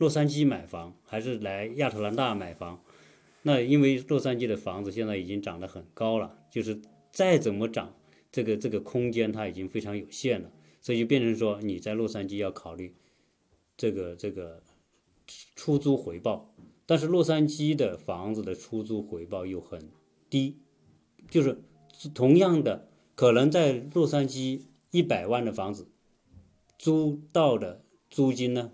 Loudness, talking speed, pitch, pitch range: -28 LUFS, 235 characters per minute, 110 Hz, 95-135 Hz